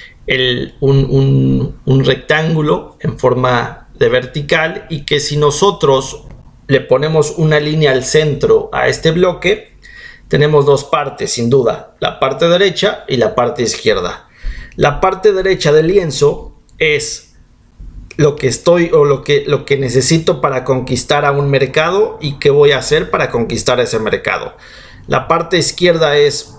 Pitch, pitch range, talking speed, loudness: 150 Hz, 135-175 Hz, 145 wpm, -13 LUFS